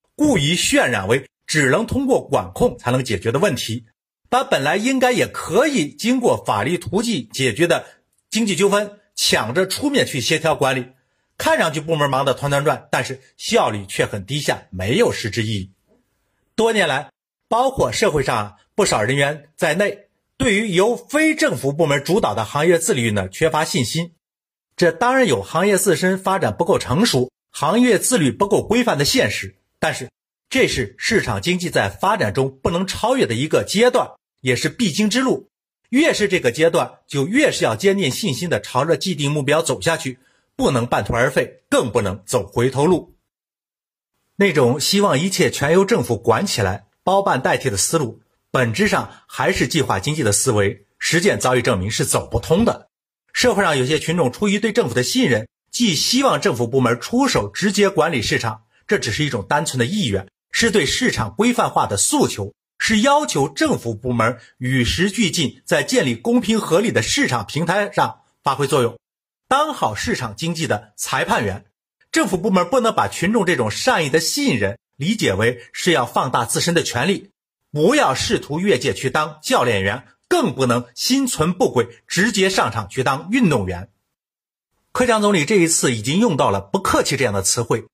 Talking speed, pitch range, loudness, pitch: 275 characters per minute, 125-205 Hz, -18 LUFS, 160 Hz